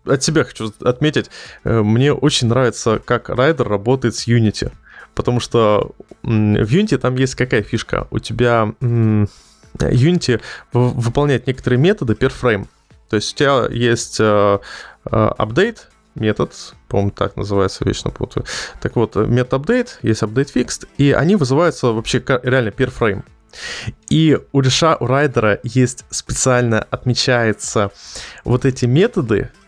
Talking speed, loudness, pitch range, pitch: 130 wpm, -17 LUFS, 110-130 Hz, 120 Hz